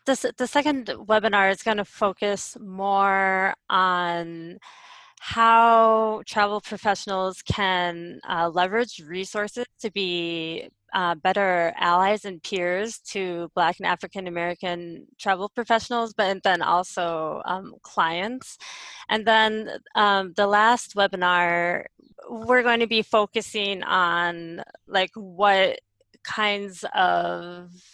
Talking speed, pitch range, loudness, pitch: 115 wpm, 180-220 Hz, -23 LUFS, 195 Hz